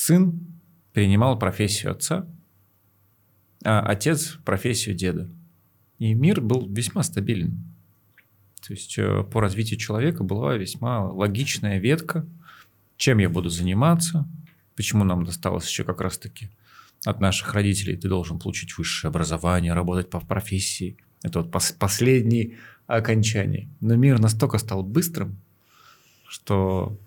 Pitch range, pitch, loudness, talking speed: 95-120 Hz, 105 Hz, -23 LUFS, 115 wpm